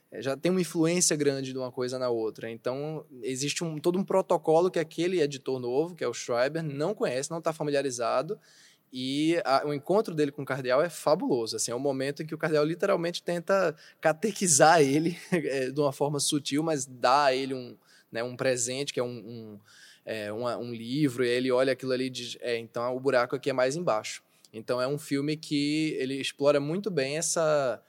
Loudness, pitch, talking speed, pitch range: -28 LUFS, 140 Hz, 205 wpm, 125-160 Hz